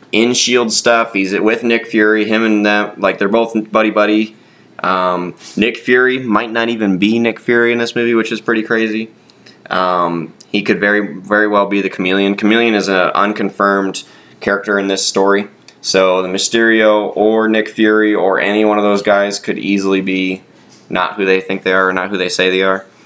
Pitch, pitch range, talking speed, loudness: 105 Hz, 95-110 Hz, 200 wpm, -13 LUFS